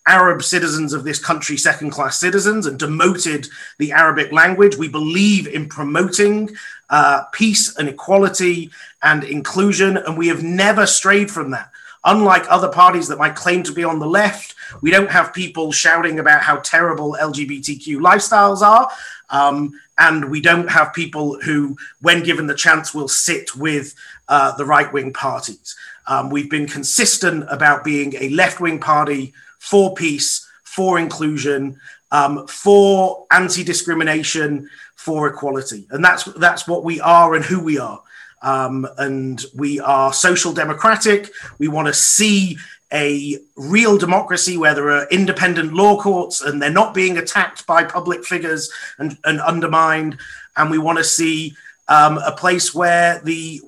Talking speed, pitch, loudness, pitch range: 155 wpm, 165 Hz, -15 LUFS, 150-185 Hz